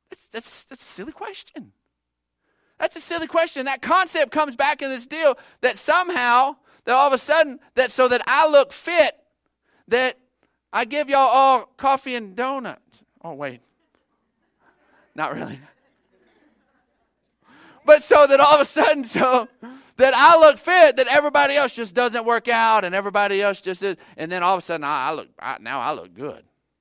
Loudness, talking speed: -18 LUFS, 180 wpm